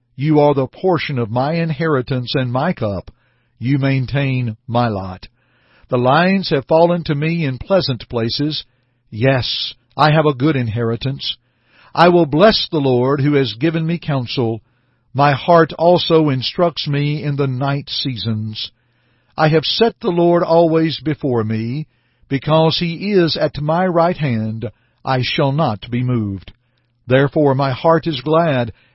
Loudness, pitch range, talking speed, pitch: -16 LUFS, 120-160 Hz, 150 wpm, 140 Hz